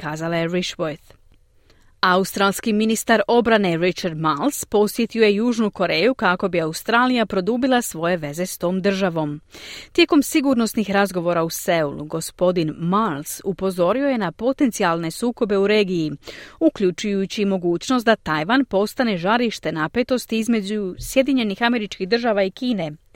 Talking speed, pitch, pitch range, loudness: 125 wpm, 200 Hz, 175-235 Hz, -20 LUFS